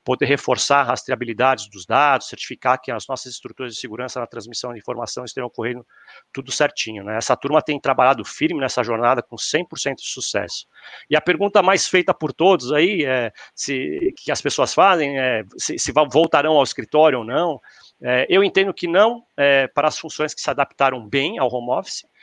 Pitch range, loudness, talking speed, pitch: 125-155 Hz, -19 LUFS, 190 wpm, 140 Hz